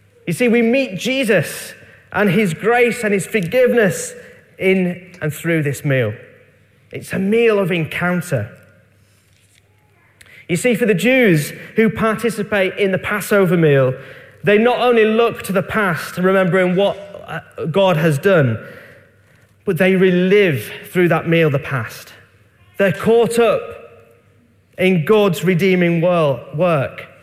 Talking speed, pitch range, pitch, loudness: 130 wpm, 140-210 Hz, 180 Hz, -16 LUFS